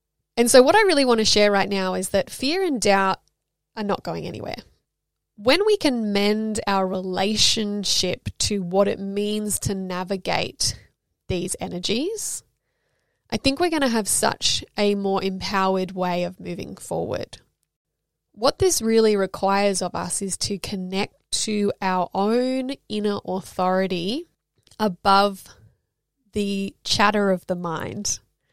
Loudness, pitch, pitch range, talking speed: -22 LUFS, 200 Hz, 190-220 Hz, 140 wpm